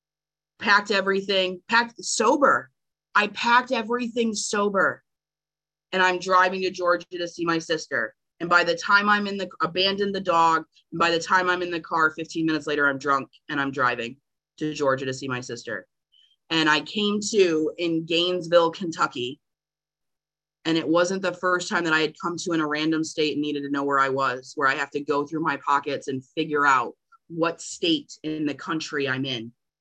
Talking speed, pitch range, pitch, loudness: 195 wpm, 150-185 Hz, 165 Hz, -23 LUFS